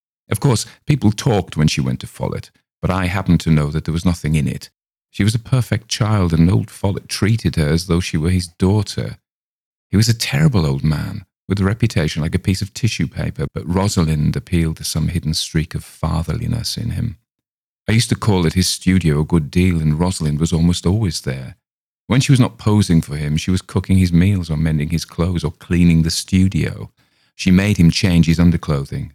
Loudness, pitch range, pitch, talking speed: -18 LUFS, 80-100 Hz, 90 Hz, 215 wpm